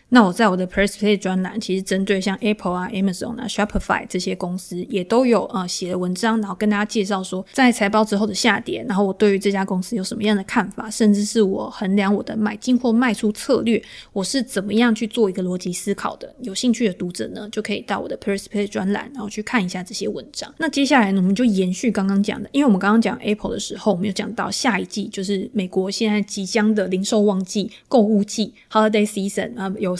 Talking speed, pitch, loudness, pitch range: 440 characters per minute, 205 Hz, -20 LUFS, 195-220 Hz